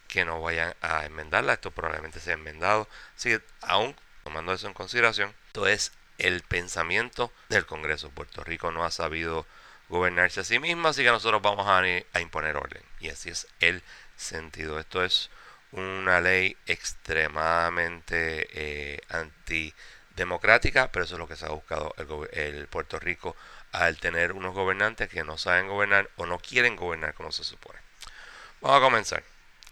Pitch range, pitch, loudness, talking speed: 80-95 Hz, 85 Hz, -27 LUFS, 160 wpm